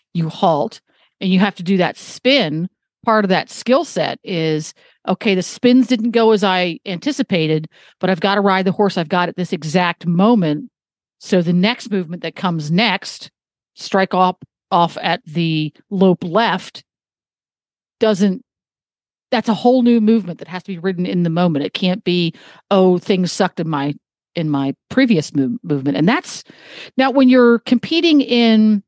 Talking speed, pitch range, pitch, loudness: 175 wpm, 170-225 Hz, 190 Hz, -16 LUFS